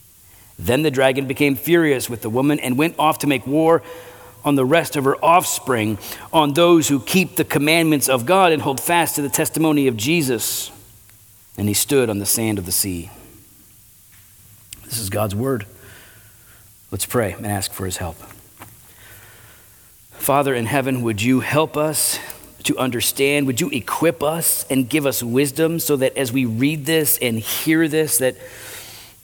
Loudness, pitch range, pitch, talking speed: -18 LUFS, 105-150 Hz, 130 Hz, 170 wpm